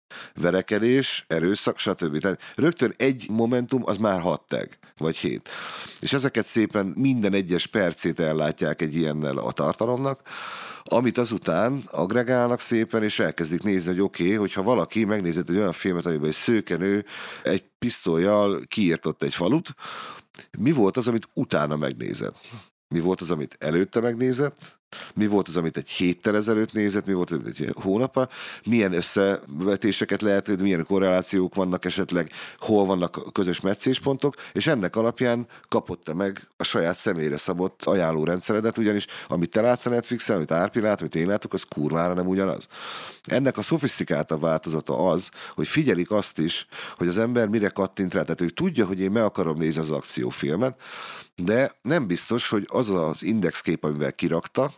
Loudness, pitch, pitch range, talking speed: -24 LUFS, 95 Hz, 85-115 Hz, 160 wpm